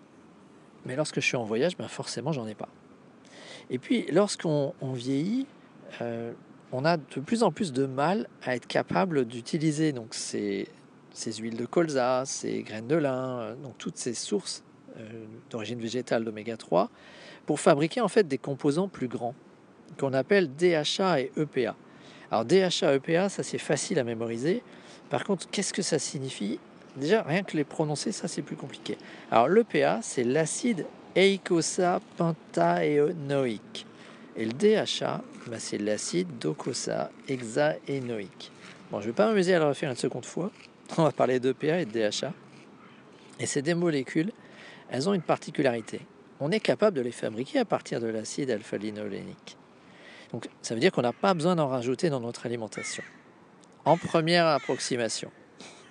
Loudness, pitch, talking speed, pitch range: -28 LUFS, 145 Hz, 165 wpm, 120-175 Hz